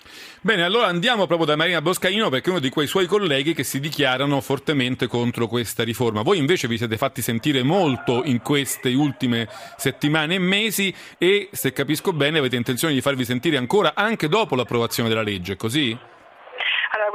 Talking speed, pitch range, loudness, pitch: 175 wpm, 125-175 Hz, -21 LUFS, 140 Hz